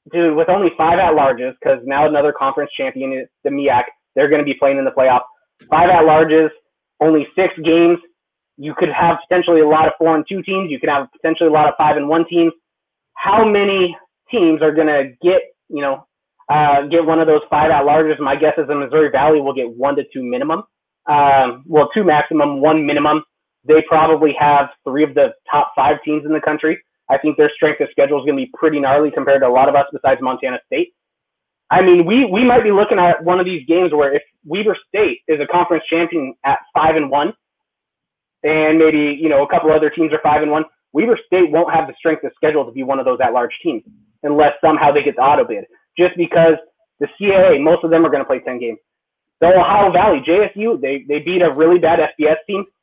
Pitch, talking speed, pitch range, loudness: 155 Hz, 225 wpm, 145-170 Hz, -14 LUFS